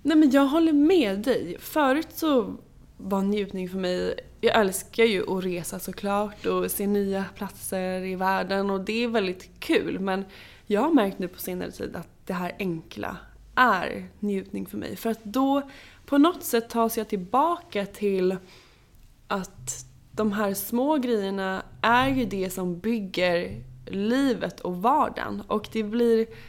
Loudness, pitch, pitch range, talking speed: -26 LUFS, 205 Hz, 185-240 Hz, 160 wpm